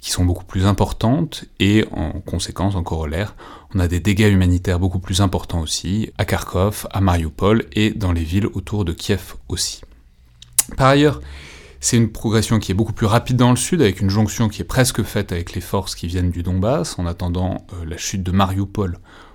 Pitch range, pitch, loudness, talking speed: 90-110 Hz, 95 Hz, -19 LUFS, 200 wpm